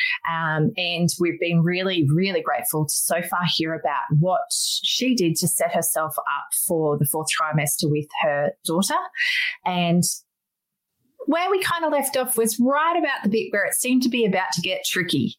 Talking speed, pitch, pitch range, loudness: 185 wpm, 180 Hz, 165-265 Hz, -22 LUFS